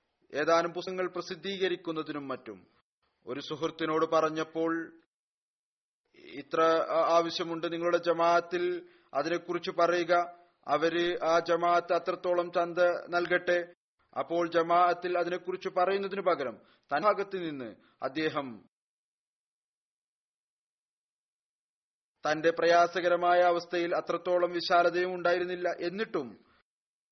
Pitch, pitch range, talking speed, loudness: 175 Hz, 165-180 Hz, 75 wpm, -29 LUFS